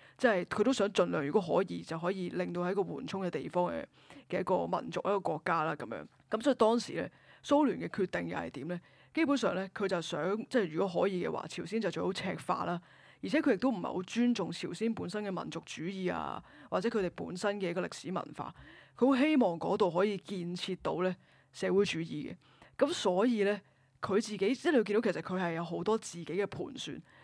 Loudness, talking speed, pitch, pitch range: -33 LUFS, 330 characters per minute, 195 Hz, 180-220 Hz